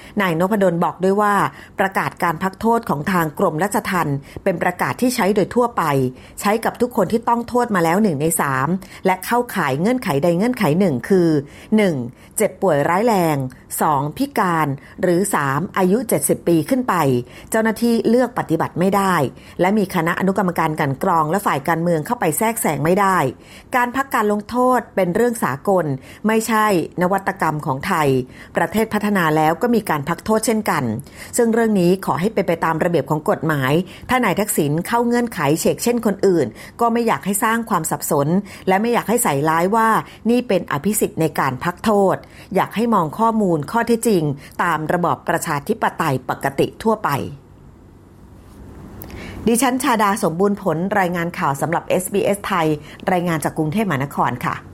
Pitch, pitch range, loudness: 185 Hz, 160-215 Hz, -19 LUFS